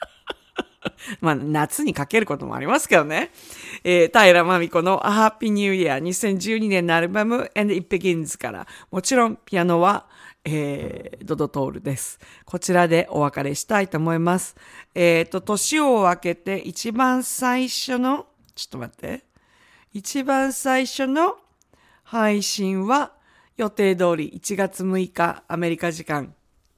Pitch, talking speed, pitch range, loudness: 190 Hz, 285 characters per minute, 170-225 Hz, -21 LUFS